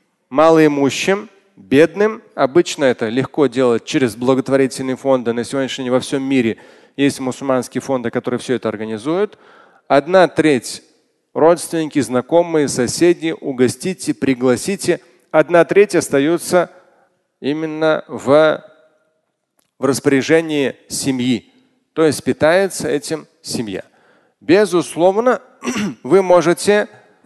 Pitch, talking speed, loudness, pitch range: 155 Hz, 100 wpm, -16 LUFS, 130-175 Hz